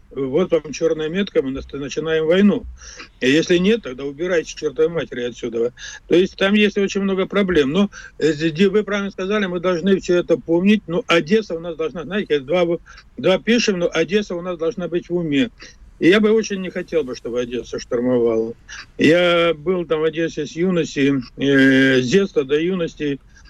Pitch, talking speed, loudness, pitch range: 170 Hz, 175 wpm, -19 LUFS, 145-195 Hz